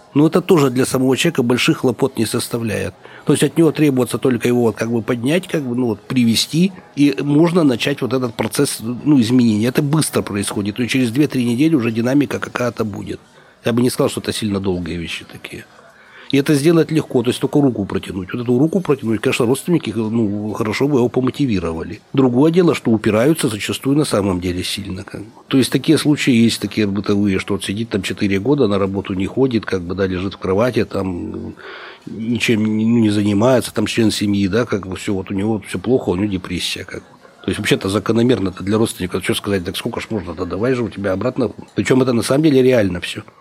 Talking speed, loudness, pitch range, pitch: 220 wpm, -17 LUFS, 105-135 Hz, 115 Hz